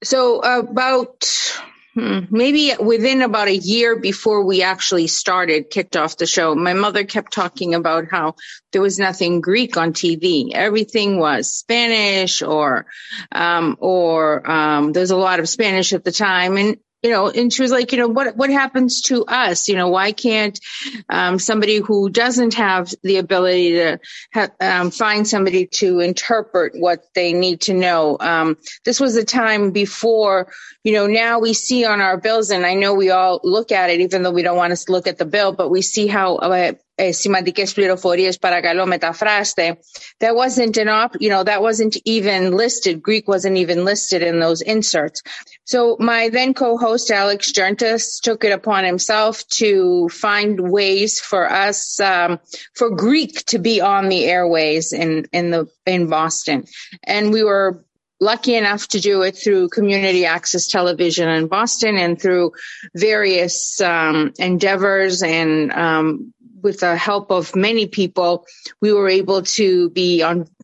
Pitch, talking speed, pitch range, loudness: 195 Hz, 165 wpm, 180-220 Hz, -16 LUFS